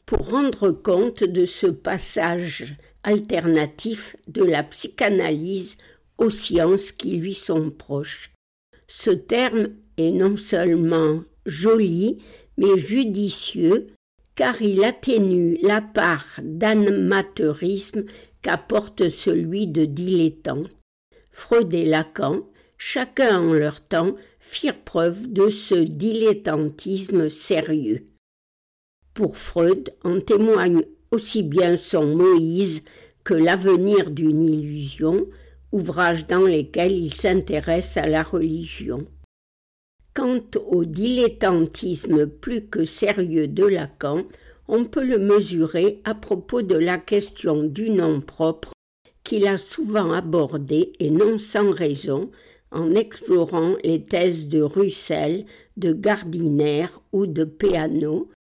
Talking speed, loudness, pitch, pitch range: 110 wpm, -21 LUFS, 180 Hz, 160-210 Hz